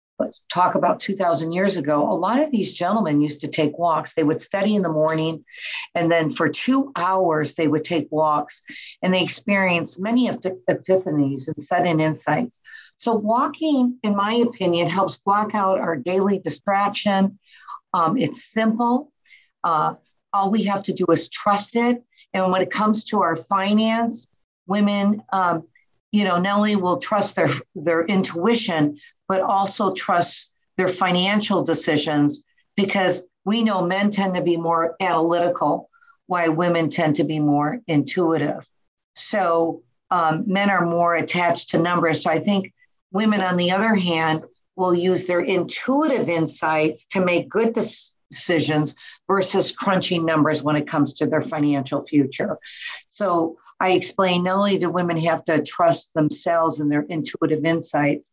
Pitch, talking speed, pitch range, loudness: 180 Hz, 155 wpm, 160-200 Hz, -21 LUFS